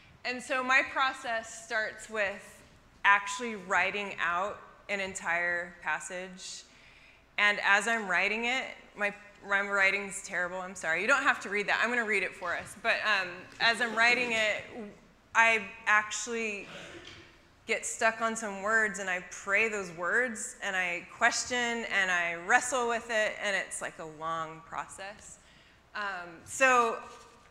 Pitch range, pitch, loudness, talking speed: 195-235 Hz, 210 Hz, -29 LUFS, 155 wpm